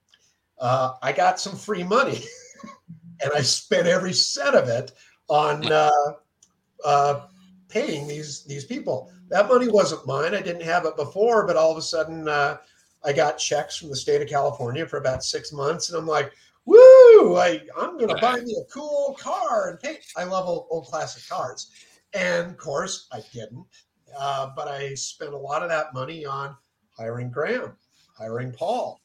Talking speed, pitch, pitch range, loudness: 180 wpm, 160 Hz, 145-220 Hz, -21 LUFS